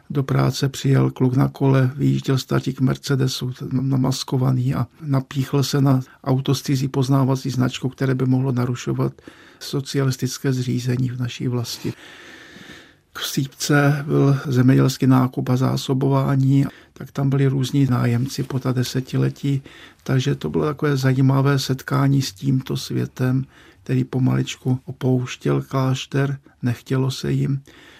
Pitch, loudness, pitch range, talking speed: 135 Hz, -21 LUFS, 130-140 Hz, 125 wpm